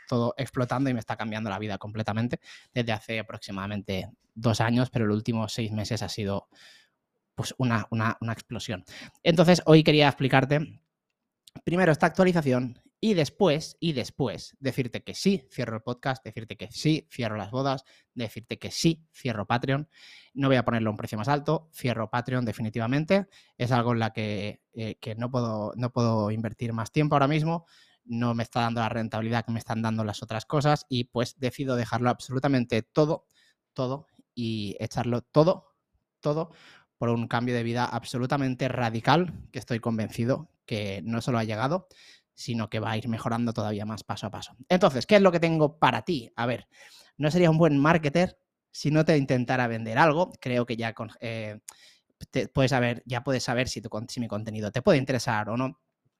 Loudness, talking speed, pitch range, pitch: -27 LUFS, 185 wpm, 110-140 Hz, 120 Hz